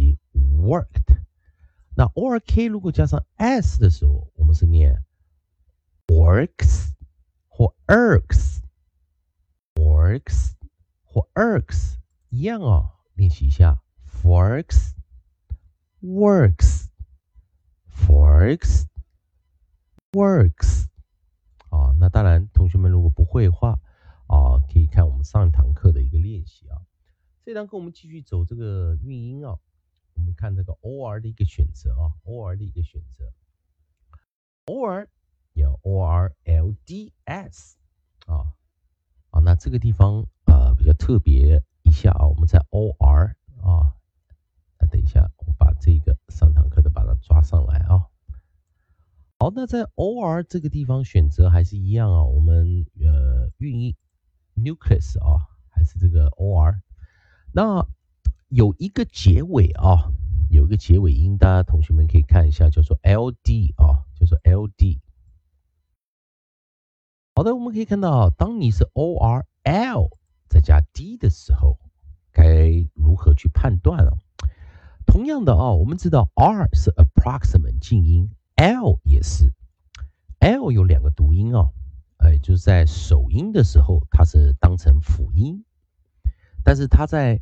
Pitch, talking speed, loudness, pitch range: 80 Hz, 230 characters per minute, -19 LUFS, 75-90 Hz